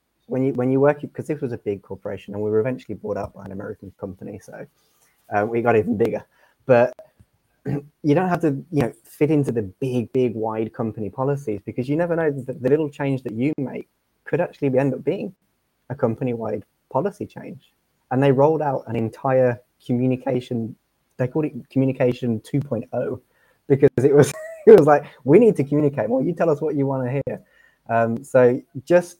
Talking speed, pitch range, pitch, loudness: 205 wpm, 115-145 Hz, 130 Hz, -21 LUFS